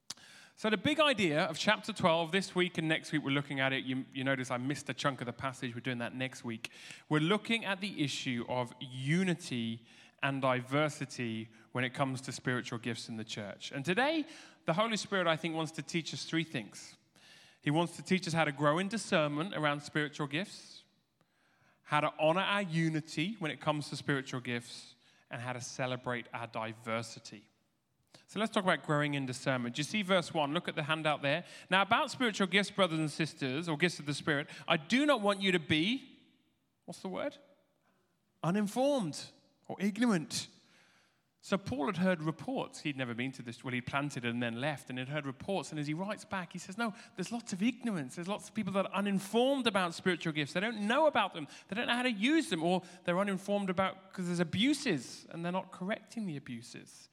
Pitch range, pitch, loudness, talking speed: 135-195 Hz, 160 Hz, -34 LUFS, 210 wpm